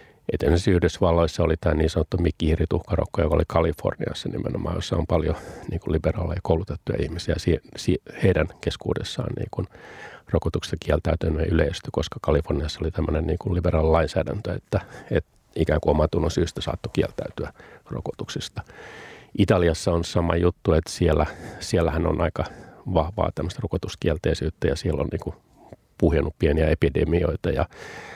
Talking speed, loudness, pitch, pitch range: 115 wpm, -24 LUFS, 85 Hz, 80-95 Hz